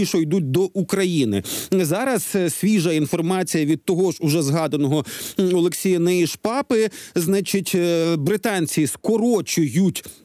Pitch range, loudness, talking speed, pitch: 160-195 Hz, -20 LUFS, 100 wpm, 180 Hz